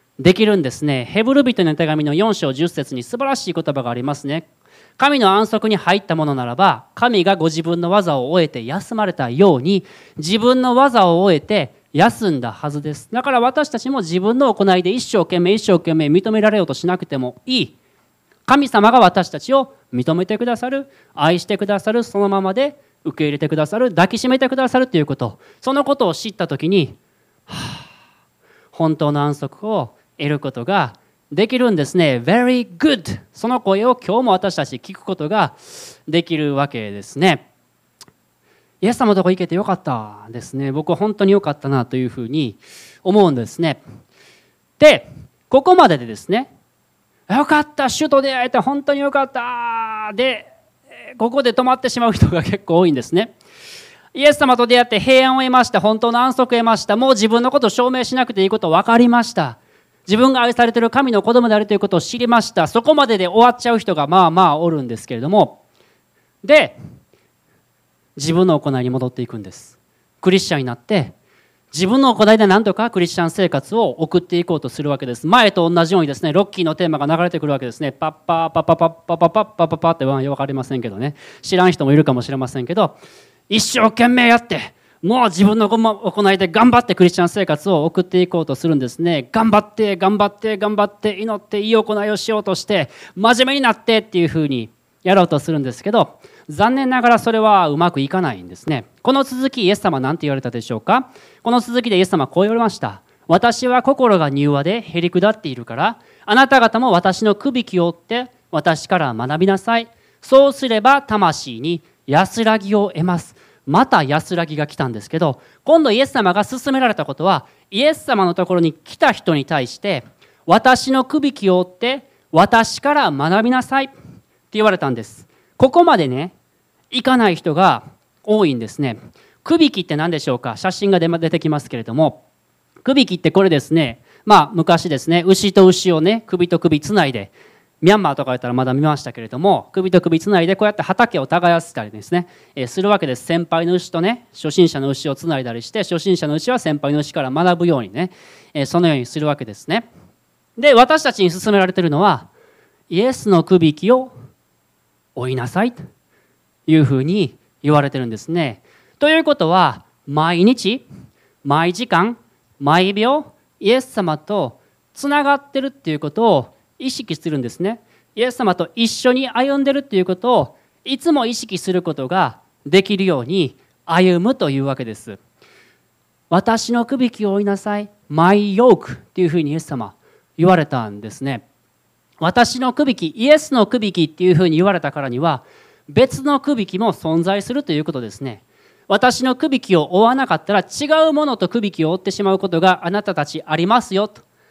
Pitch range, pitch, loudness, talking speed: 155-230 Hz, 185 Hz, -16 LUFS, 375 characters per minute